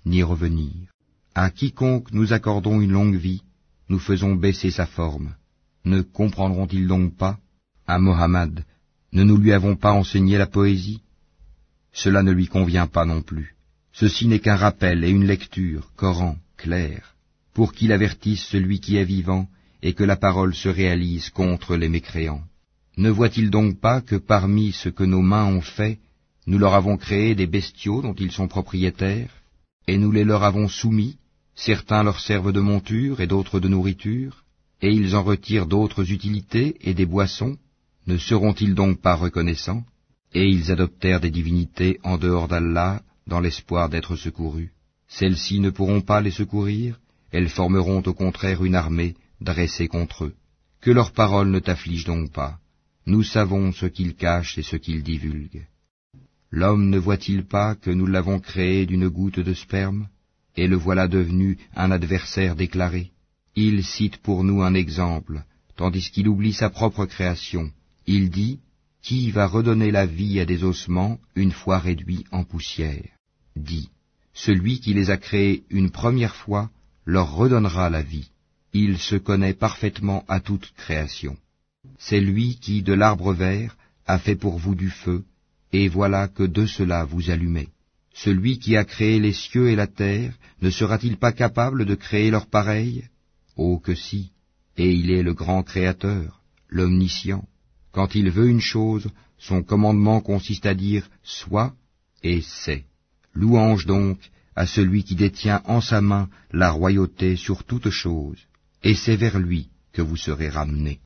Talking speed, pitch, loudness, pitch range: 165 wpm, 95 Hz, -22 LUFS, 85-105 Hz